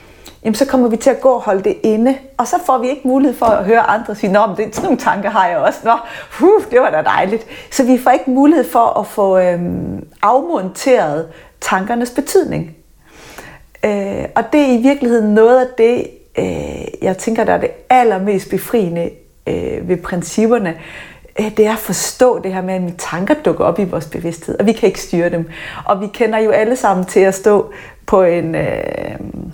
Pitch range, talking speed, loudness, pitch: 190-255 Hz, 210 wpm, -14 LUFS, 225 Hz